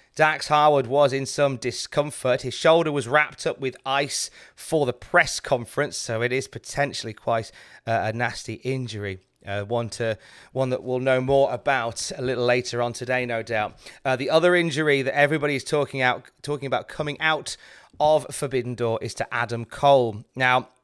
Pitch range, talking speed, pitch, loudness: 120-145 Hz, 180 wpm, 130 Hz, -23 LUFS